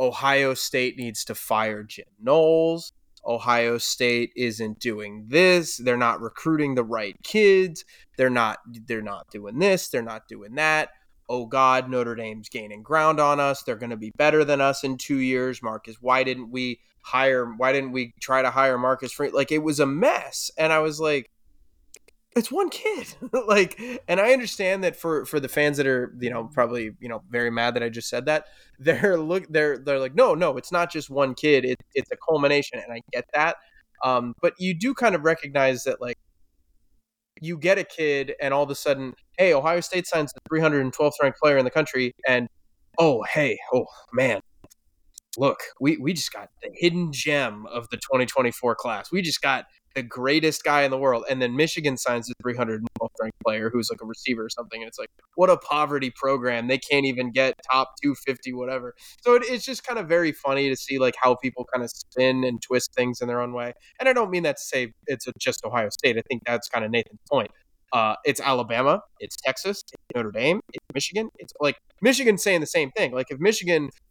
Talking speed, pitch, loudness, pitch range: 210 wpm, 130 Hz, -23 LUFS, 120-155 Hz